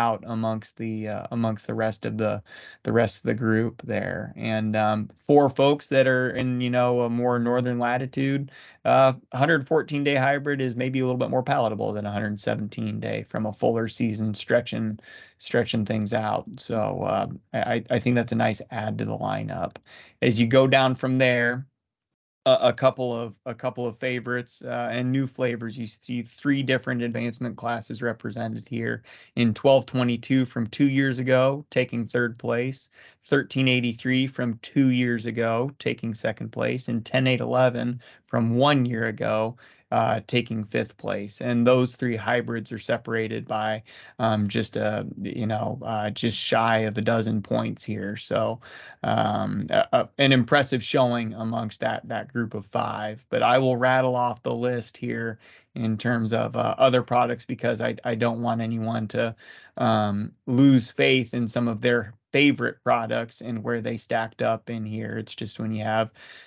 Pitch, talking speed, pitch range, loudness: 120 Hz, 170 wpm, 110-125 Hz, -25 LUFS